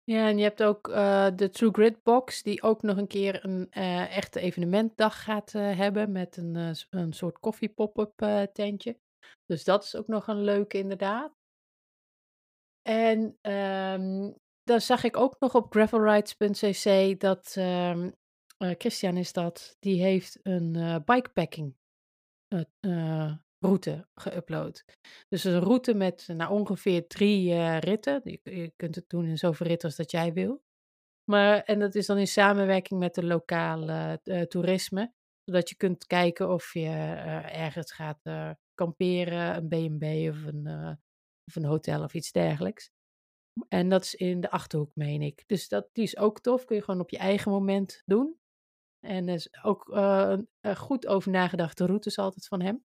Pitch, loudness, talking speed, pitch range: 190 Hz, -28 LUFS, 170 wpm, 170-210 Hz